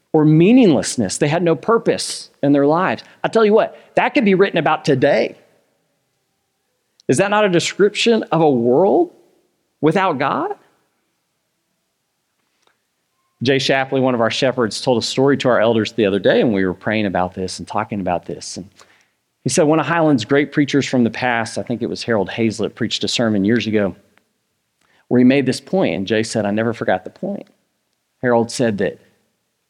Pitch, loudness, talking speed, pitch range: 135 Hz, -17 LUFS, 185 wpm, 115-165 Hz